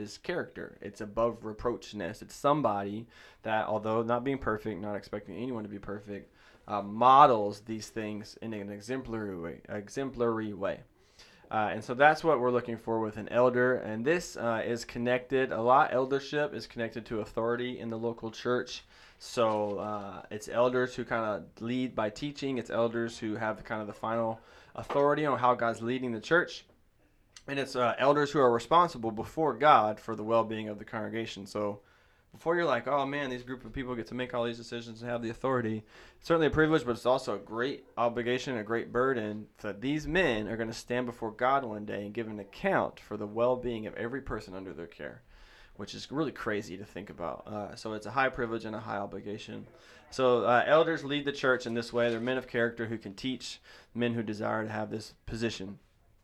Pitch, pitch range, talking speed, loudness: 115 Hz, 105-125 Hz, 205 wpm, -31 LUFS